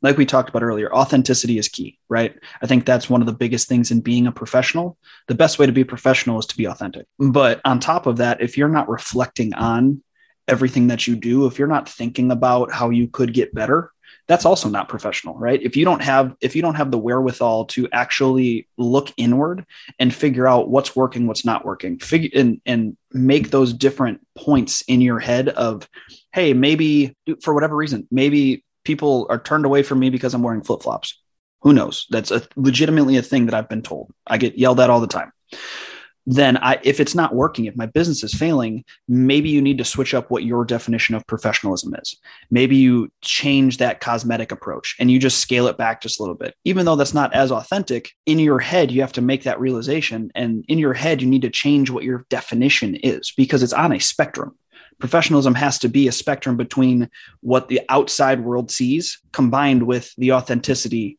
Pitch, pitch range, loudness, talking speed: 130 Hz, 120-140 Hz, -18 LUFS, 210 wpm